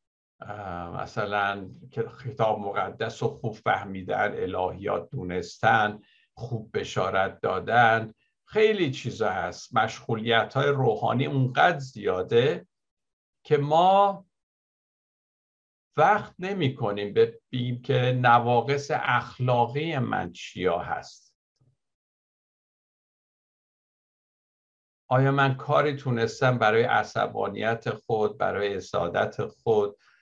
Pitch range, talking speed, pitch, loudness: 110-140 Hz, 80 wpm, 125 Hz, -26 LUFS